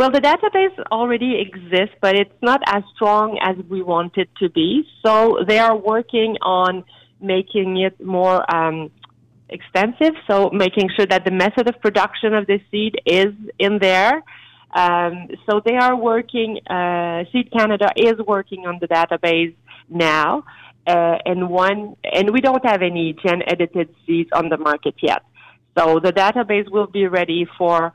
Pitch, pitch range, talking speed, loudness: 195 Hz, 175-220 Hz, 165 wpm, -18 LUFS